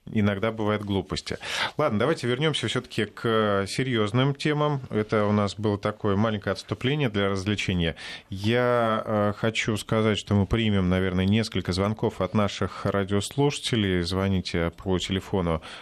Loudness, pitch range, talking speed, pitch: -25 LUFS, 95-115 Hz, 135 wpm, 105 Hz